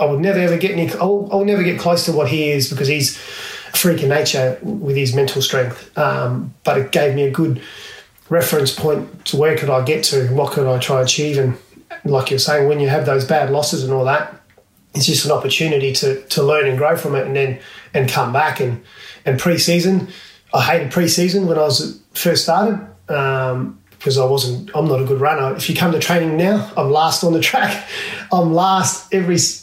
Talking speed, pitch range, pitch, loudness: 220 wpm, 135-170 Hz, 150 Hz, -16 LUFS